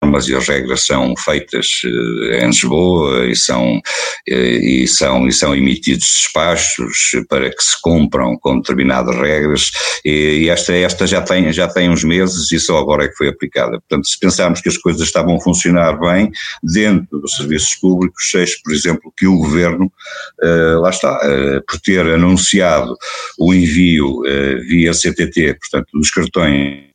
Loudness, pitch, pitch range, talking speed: -13 LUFS, 80 Hz, 70-90 Hz, 165 wpm